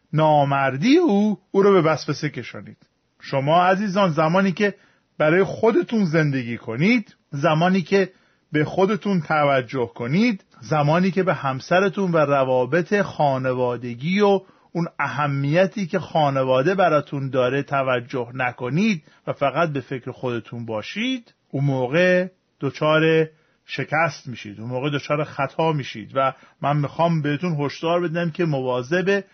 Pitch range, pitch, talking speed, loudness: 135-185 Hz, 155 Hz, 125 wpm, -21 LUFS